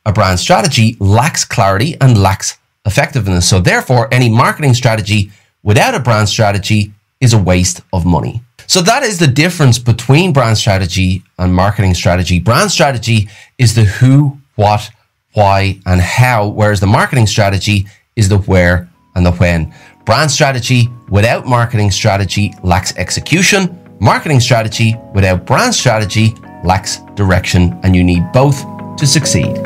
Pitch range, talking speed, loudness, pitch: 95-125 Hz, 145 wpm, -11 LUFS, 110 Hz